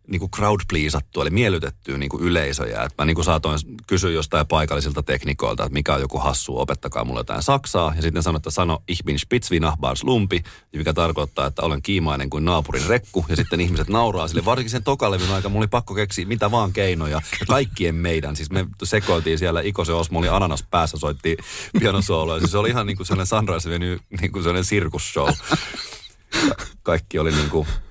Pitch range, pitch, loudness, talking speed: 80-100 Hz, 85 Hz, -21 LUFS, 190 wpm